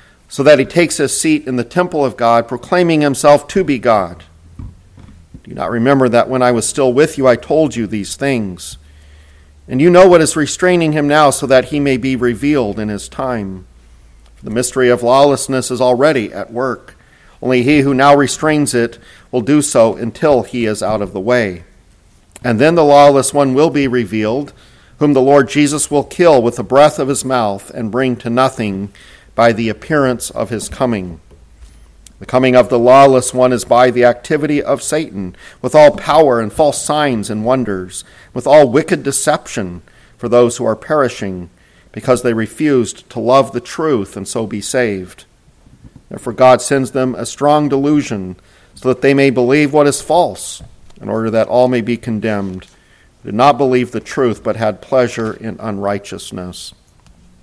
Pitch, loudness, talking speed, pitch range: 125 Hz, -13 LUFS, 185 wpm, 105-140 Hz